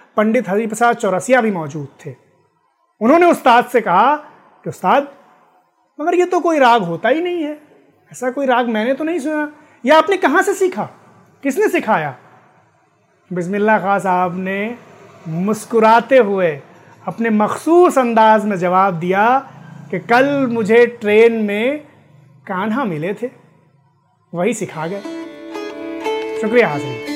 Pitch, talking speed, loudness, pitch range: 230 Hz, 135 wpm, -15 LUFS, 185-285 Hz